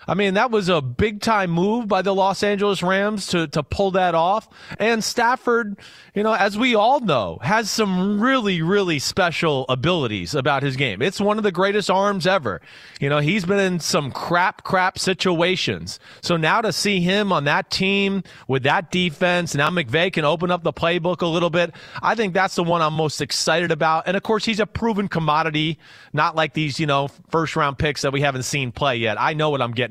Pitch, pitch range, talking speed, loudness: 180 Hz, 155-200 Hz, 215 wpm, -20 LUFS